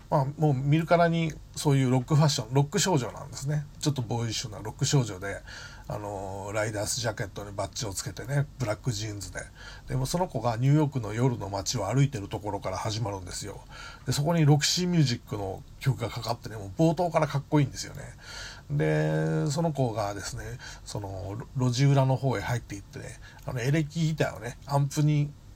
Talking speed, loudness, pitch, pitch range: 455 characters per minute, -28 LUFS, 130 Hz, 105-145 Hz